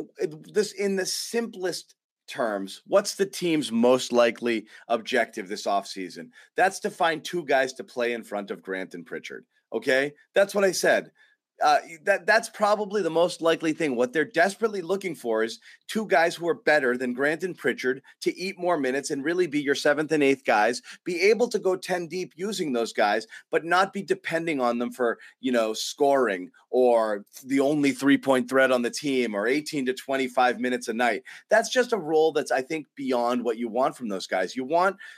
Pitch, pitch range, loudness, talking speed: 150 Hz, 125-190 Hz, -25 LUFS, 200 wpm